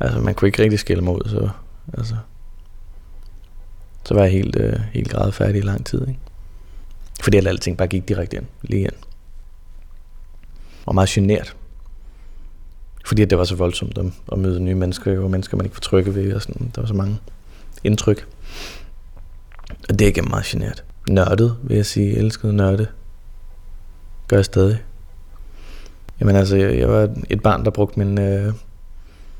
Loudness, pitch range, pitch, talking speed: -19 LUFS, 85-105 Hz, 95 Hz, 170 wpm